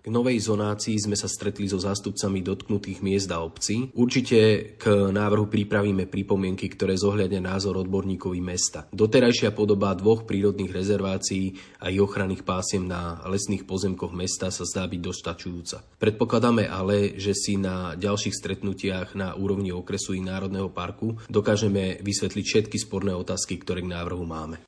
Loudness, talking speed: -26 LUFS, 150 wpm